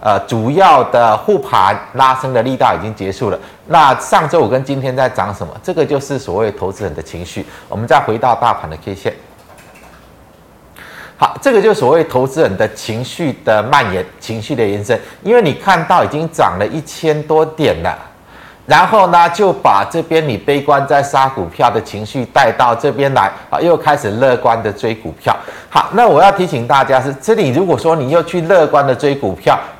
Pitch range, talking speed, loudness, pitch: 105-155 Hz, 280 characters per minute, -13 LUFS, 135 Hz